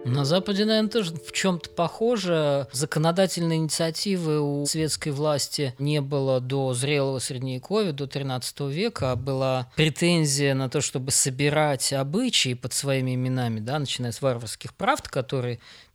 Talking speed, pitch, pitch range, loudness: 140 wpm, 145 Hz, 130-160 Hz, -25 LUFS